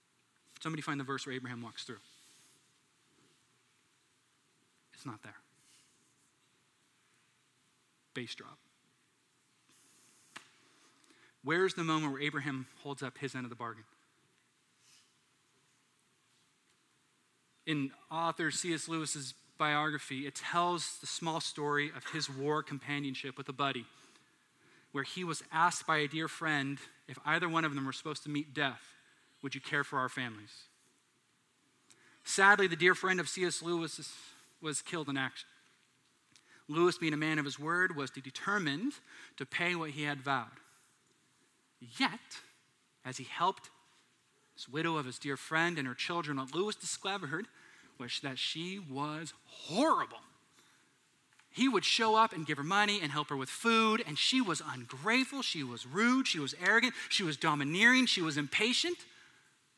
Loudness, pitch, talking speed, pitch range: -33 LUFS, 150 Hz, 145 wpm, 140-175 Hz